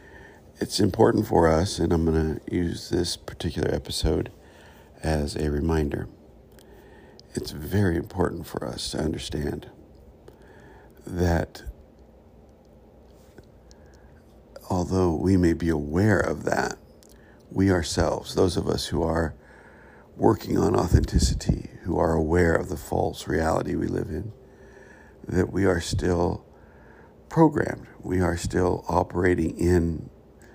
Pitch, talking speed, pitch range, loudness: 85 Hz, 120 wpm, 75-90 Hz, -25 LUFS